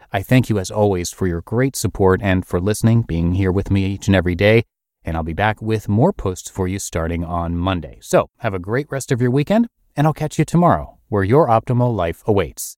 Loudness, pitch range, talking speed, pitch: -18 LUFS, 90-120 Hz, 235 wpm, 100 Hz